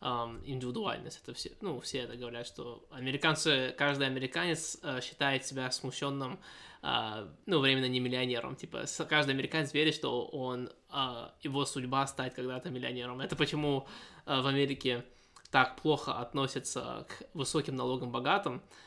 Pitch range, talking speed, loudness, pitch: 125-145 Hz, 125 wpm, -34 LUFS, 135 Hz